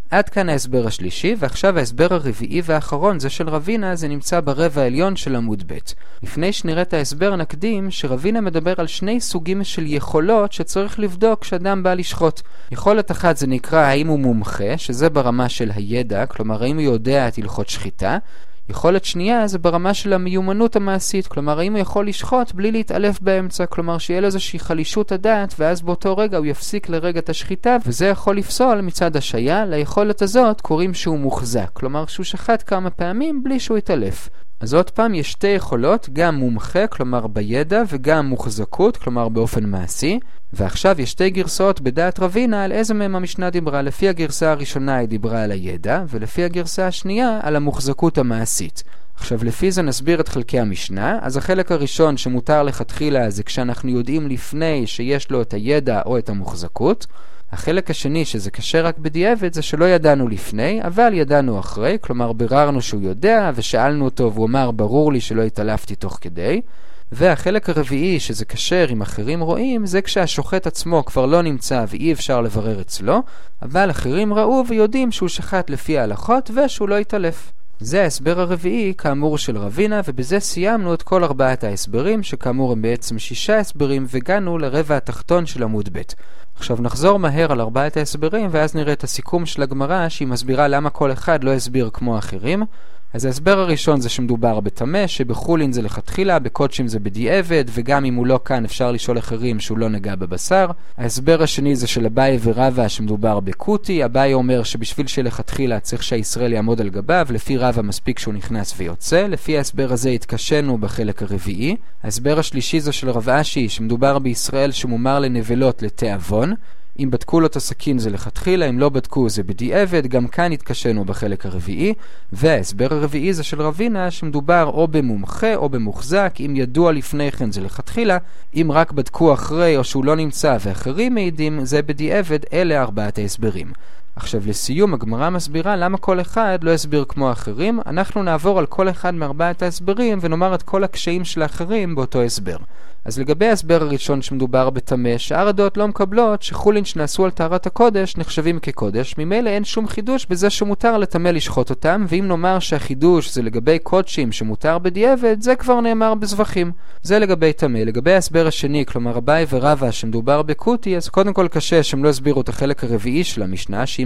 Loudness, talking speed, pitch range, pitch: -19 LUFS, 165 wpm, 125-185 Hz, 150 Hz